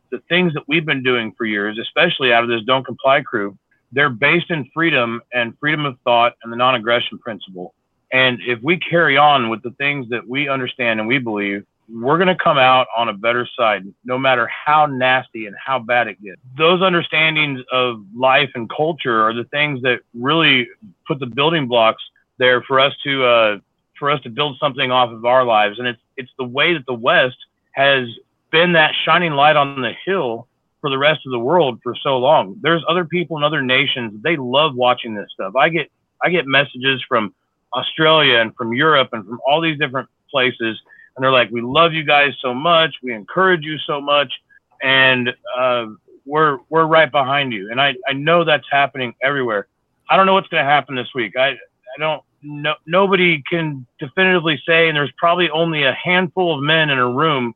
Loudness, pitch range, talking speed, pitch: -16 LUFS, 120-155 Hz, 205 wpm, 135 Hz